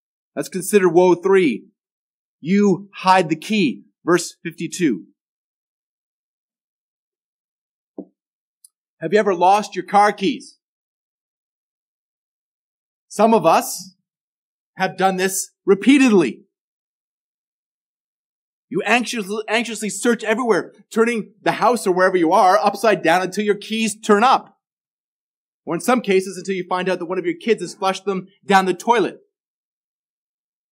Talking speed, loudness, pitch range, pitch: 120 wpm, -18 LUFS, 180-215 Hz, 195 Hz